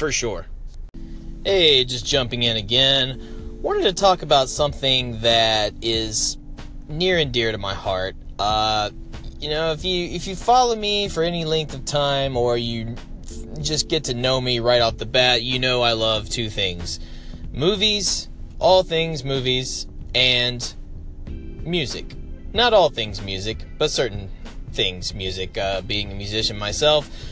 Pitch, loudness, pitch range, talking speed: 120 Hz, -20 LUFS, 95-150 Hz, 155 wpm